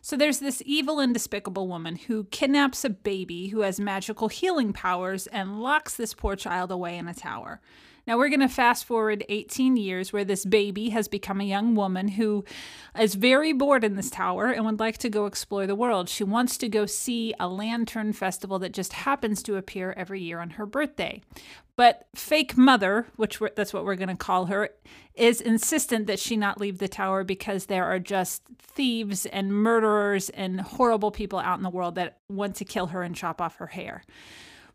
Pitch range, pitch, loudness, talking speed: 195-240 Hz, 210 Hz, -26 LUFS, 205 wpm